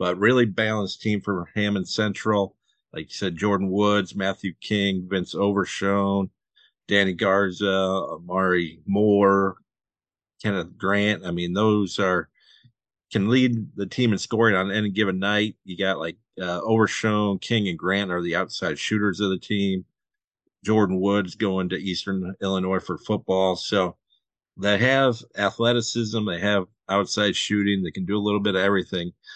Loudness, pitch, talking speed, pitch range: -23 LUFS, 100 Hz, 155 wpm, 95-105 Hz